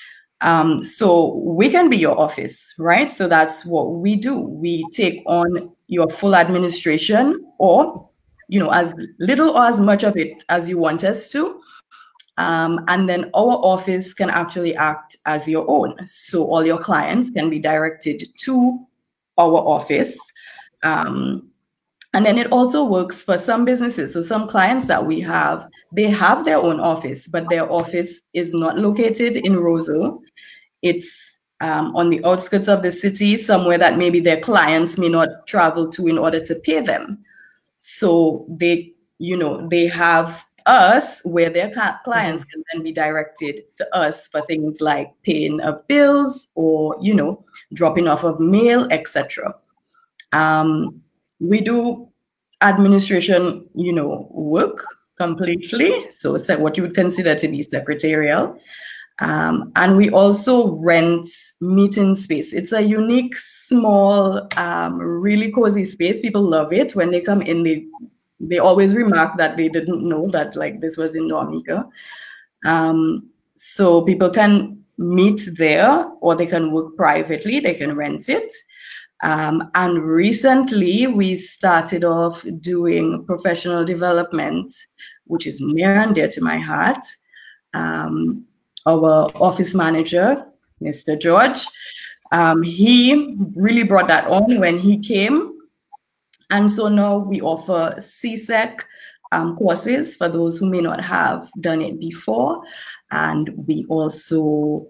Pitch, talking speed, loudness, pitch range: 175 Hz, 145 wpm, -17 LUFS, 160-210 Hz